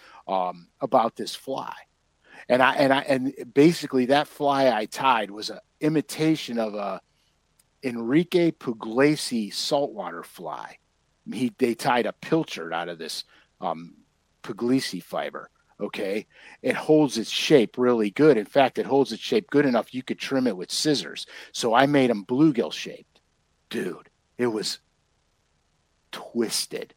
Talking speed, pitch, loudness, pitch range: 145 wpm, 125 Hz, -24 LUFS, 105-140 Hz